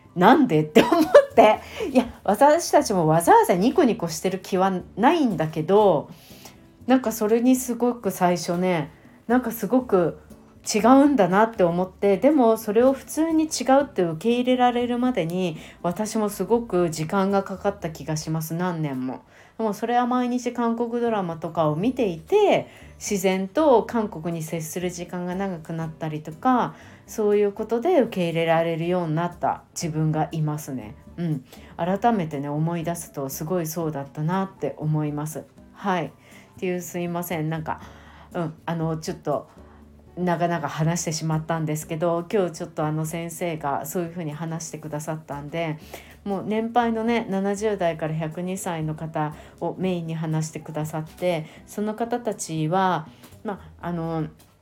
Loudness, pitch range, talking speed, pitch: -23 LUFS, 160-220 Hz, 325 characters per minute, 175 Hz